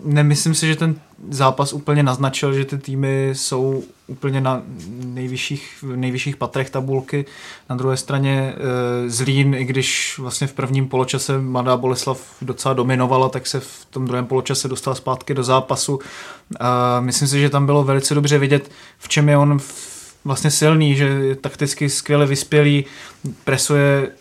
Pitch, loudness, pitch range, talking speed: 135 Hz, -18 LUFS, 130-145 Hz, 155 wpm